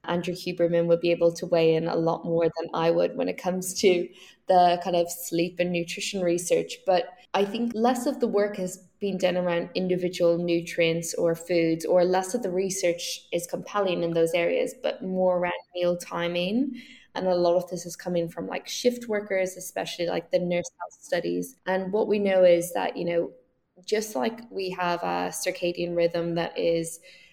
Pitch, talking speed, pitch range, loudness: 175 Hz, 195 wpm, 170-190 Hz, -26 LUFS